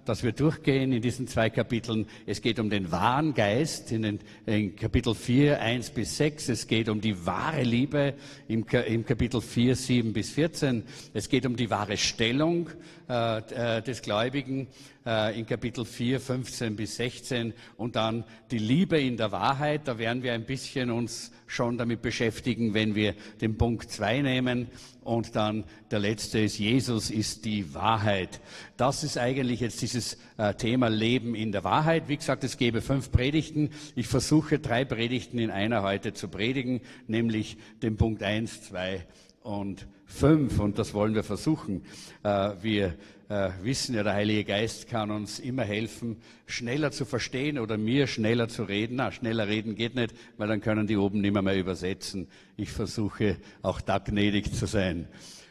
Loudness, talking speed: -28 LUFS, 170 wpm